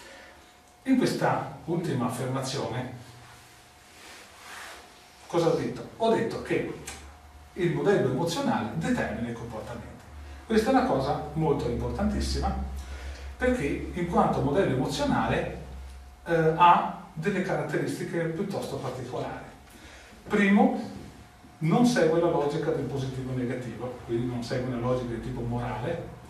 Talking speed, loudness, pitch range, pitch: 115 wpm, -28 LUFS, 115-165 Hz, 130 Hz